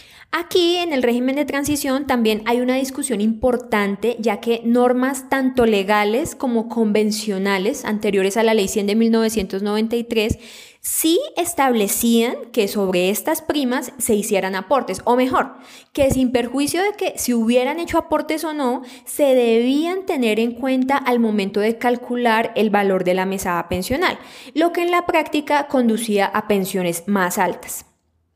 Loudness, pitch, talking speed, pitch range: -19 LUFS, 235 Hz, 150 wpm, 210-270 Hz